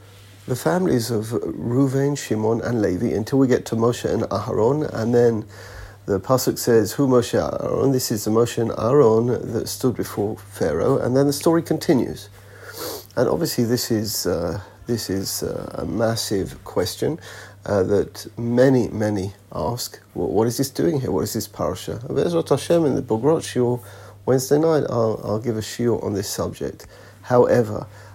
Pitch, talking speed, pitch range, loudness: 115 Hz, 160 wpm, 105-130 Hz, -21 LUFS